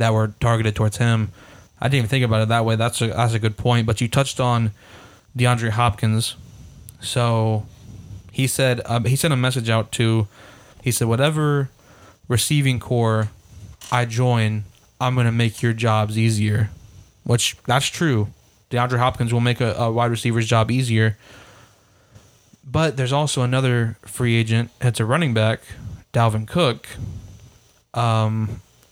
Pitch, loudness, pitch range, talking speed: 115 Hz, -20 LUFS, 110-125 Hz, 155 wpm